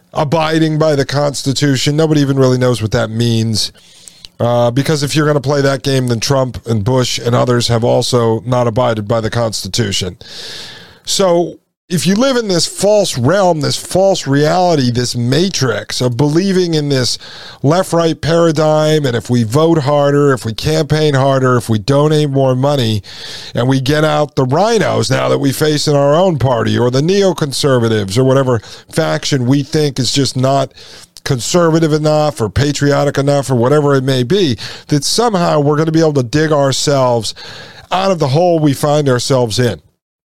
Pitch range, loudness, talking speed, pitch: 125-155 Hz, -13 LUFS, 180 wpm, 140 Hz